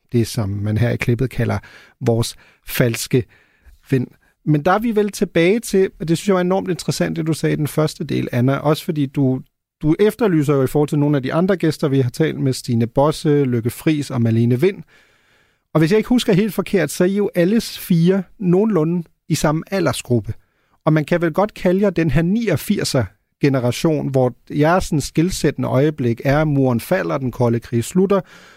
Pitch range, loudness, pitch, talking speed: 130-180 Hz, -18 LUFS, 155 Hz, 205 wpm